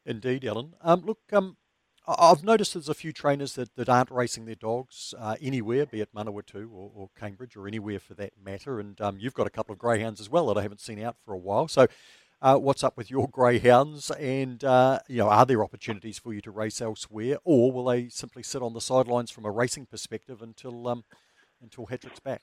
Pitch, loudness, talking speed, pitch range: 120 Hz, -26 LUFS, 225 wpm, 110-130 Hz